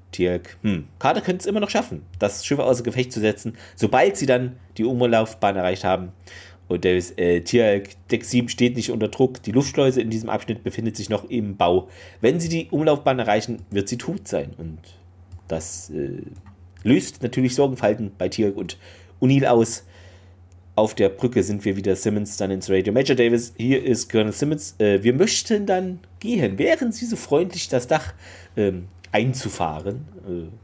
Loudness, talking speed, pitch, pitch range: -22 LUFS, 175 wpm, 110 Hz, 95-125 Hz